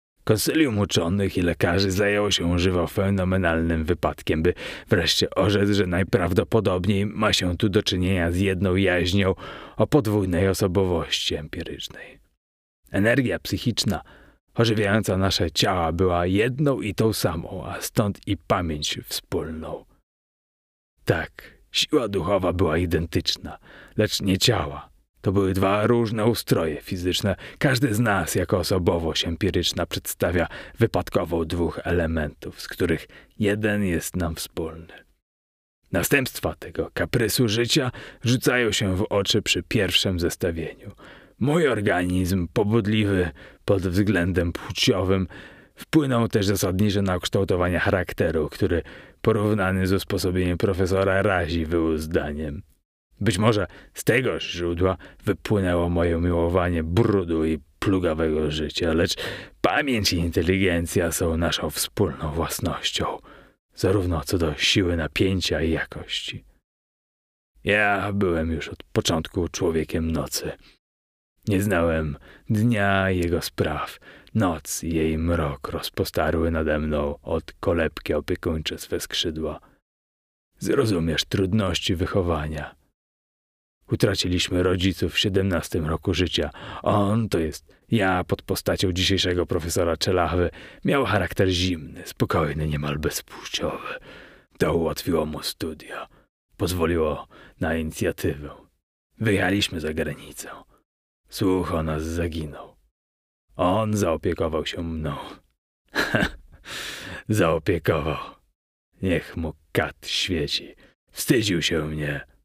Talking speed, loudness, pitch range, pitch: 110 wpm, -24 LUFS, 80-100 Hz, 90 Hz